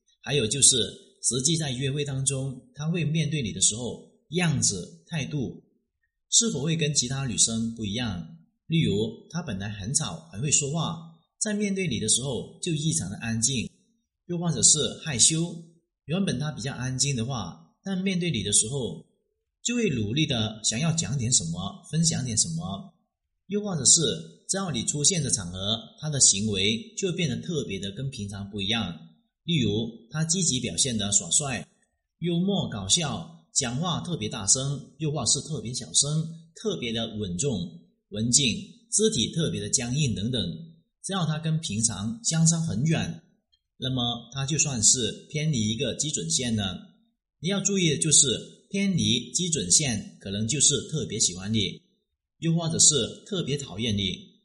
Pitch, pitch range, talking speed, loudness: 145 Hz, 115-175 Hz, 245 characters per minute, -25 LUFS